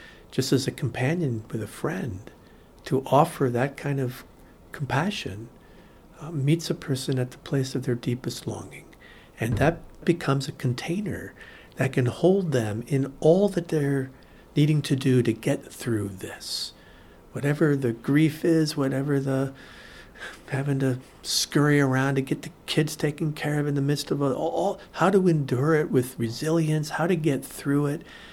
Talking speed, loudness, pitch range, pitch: 165 wpm, -26 LUFS, 130-155 Hz, 140 Hz